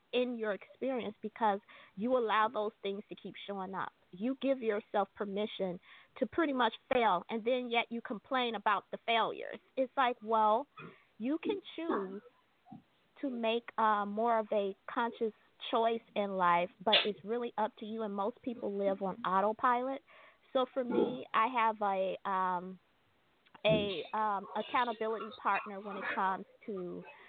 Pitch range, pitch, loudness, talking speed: 200-245 Hz, 220 Hz, -34 LUFS, 155 wpm